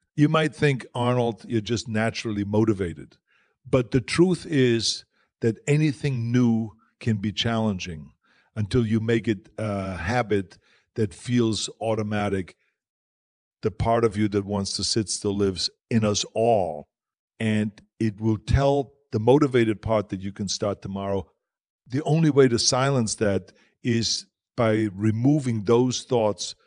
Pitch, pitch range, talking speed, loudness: 110 Hz, 100-120 Hz, 140 wpm, -24 LUFS